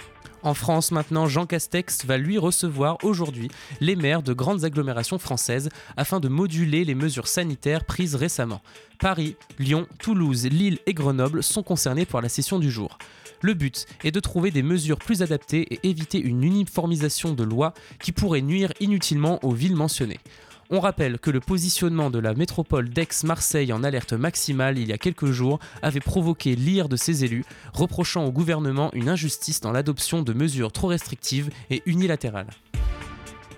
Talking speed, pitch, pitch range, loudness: 170 wpm, 155 Hz, 130-175 Hz, -24 LUFS